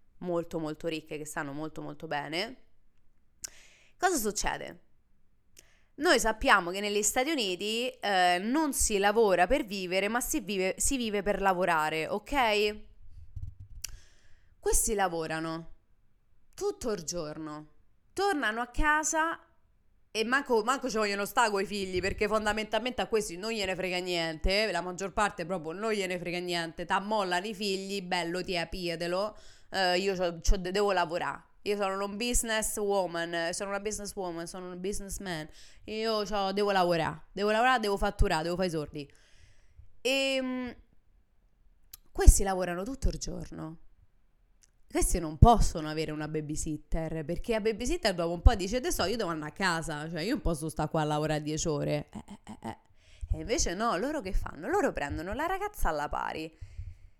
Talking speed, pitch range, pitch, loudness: 155 wpm, 160-215 Hz, 190 Hz, -30 LUFS